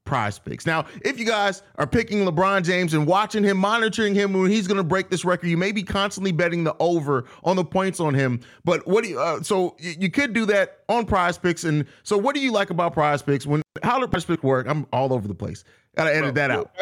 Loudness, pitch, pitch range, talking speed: -22 LUFS, 185 Hz, 155-200 Hz, 250 wpm